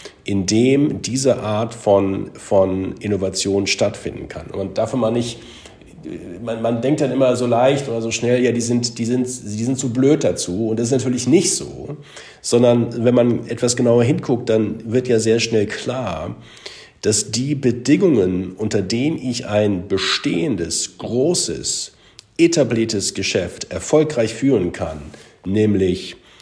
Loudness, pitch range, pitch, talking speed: -18 LUFS, 105-125 Hz, 115 Hz, 155 wpm